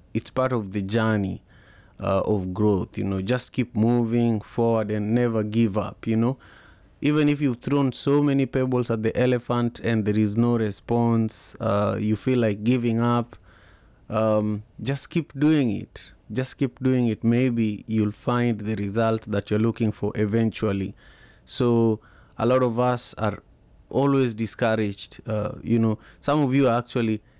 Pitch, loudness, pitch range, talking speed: 115 Hz, -24 LUFS, 105-125 Hz, 165 wpm